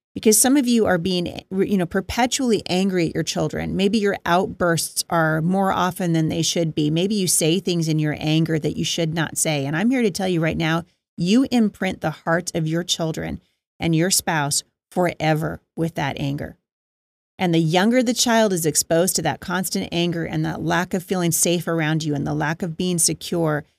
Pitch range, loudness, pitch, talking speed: 160-190 Hz, -21 LUFS, 170 Hz, 205 wpm